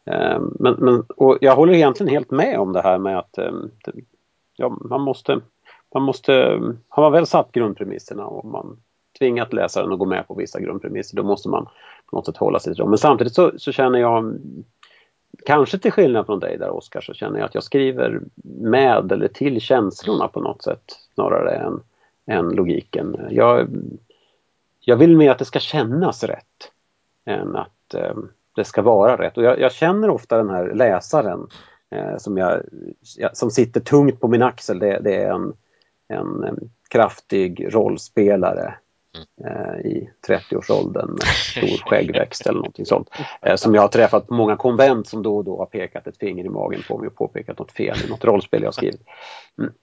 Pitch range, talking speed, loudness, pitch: 110-145 Hz, 185 wpm, -19 LUFS, 125 Hz